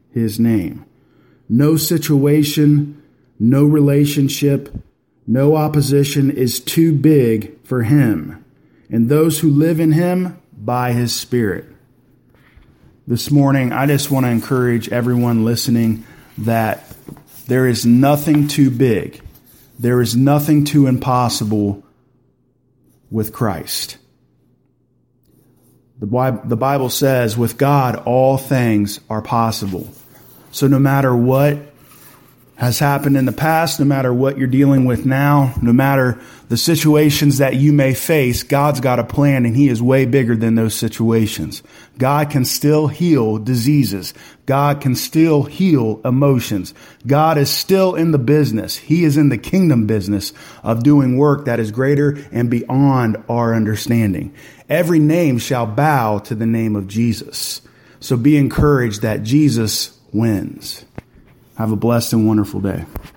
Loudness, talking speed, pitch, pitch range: -15 LUFS, 135 wpm, 130 Hz, 115-145 Hz